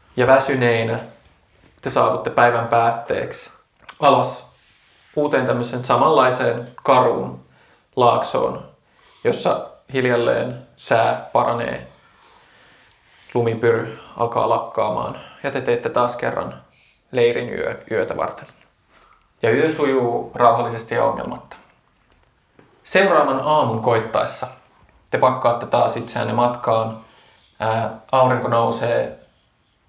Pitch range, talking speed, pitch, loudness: 115-125 Hz, 90 wpm, 115 Hz, -19 LUFS